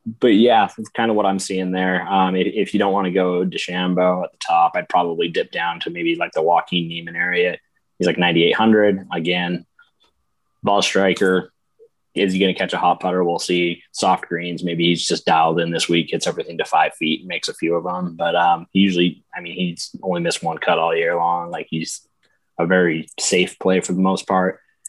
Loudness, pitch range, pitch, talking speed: -19 LUFS, 85-95 Hz, 90 Hz, 215 wpm